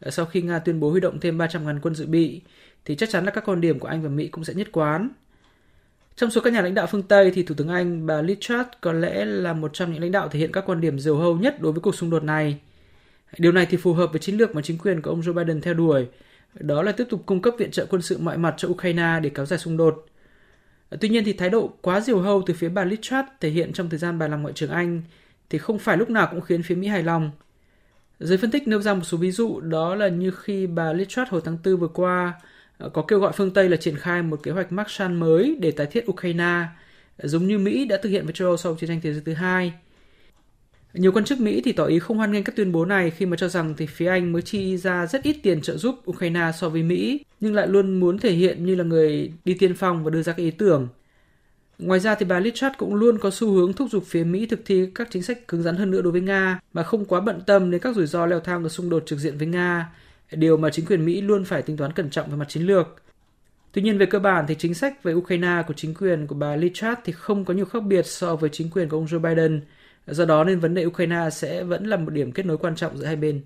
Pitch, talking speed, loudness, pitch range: 175 Hz, 280 wpm, -22 LUFS, 165-195 Hz